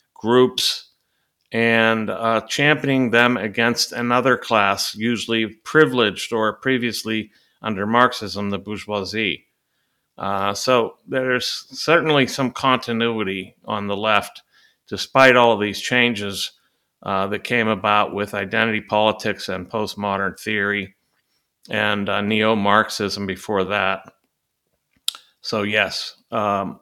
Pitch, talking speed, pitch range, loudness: 110 Hz, 110 wpm, 100-120 Hz, -20 LUFS